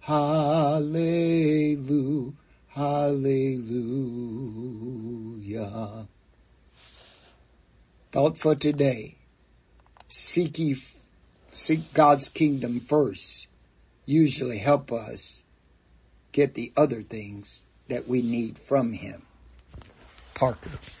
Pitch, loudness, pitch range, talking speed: 125 Hz, -26 LUFS, 105-145 Hz, 70 wpm